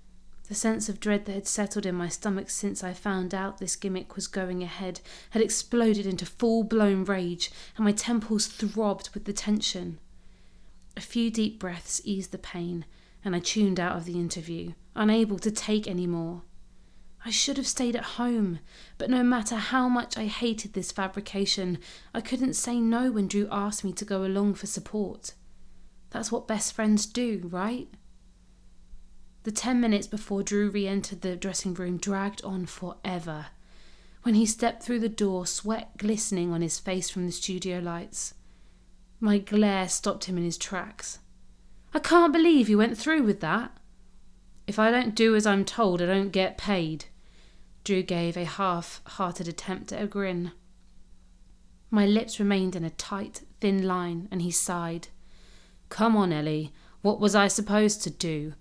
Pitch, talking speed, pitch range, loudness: 195 Hz, 170 wpm, 175-215 Hz, -28 LUFS